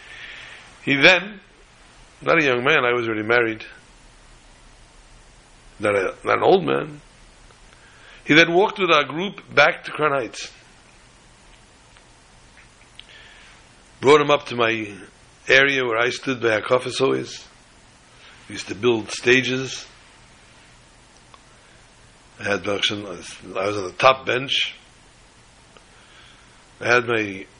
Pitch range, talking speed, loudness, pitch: 105-130 Hz, 115 wpm, -19 LUFS, 120 Hz